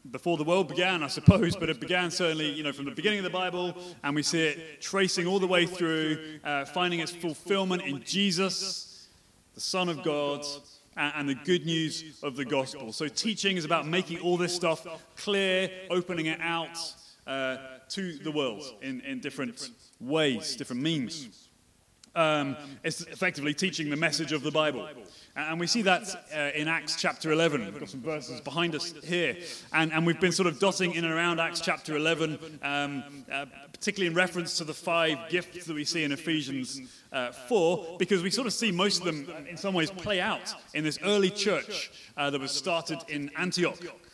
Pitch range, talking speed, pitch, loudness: 150-180 Hz, 195 wpm, 165 Hz, -29 LUFS